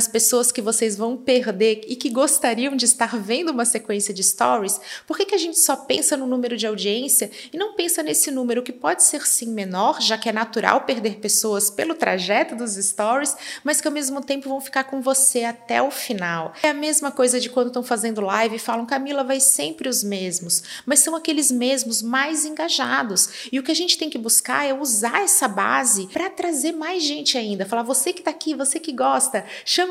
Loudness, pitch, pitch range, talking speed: -20 LUFS, 255 Hz, 230-295 Hz, 215 wpm